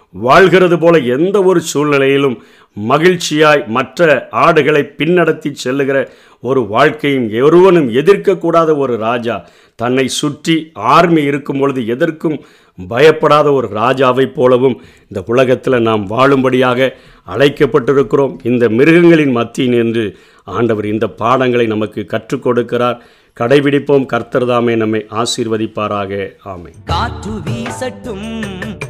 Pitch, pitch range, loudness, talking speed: 130 Hz, 115-150 Hz, -12 LUFS, 100 wpm